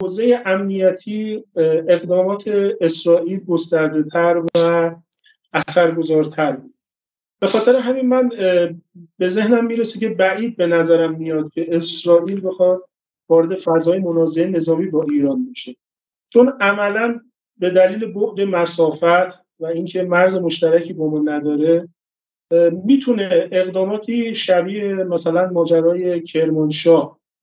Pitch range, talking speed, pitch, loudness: 165-200 Hz, 110 wpm, 175 Hz, -17 LUFS